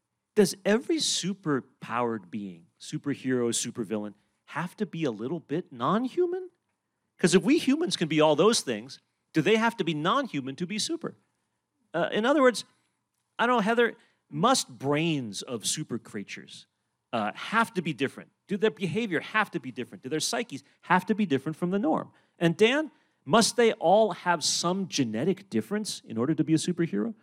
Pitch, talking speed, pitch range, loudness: 175 Hz, 185 wpm, 140-220 Hz, -27 LUFS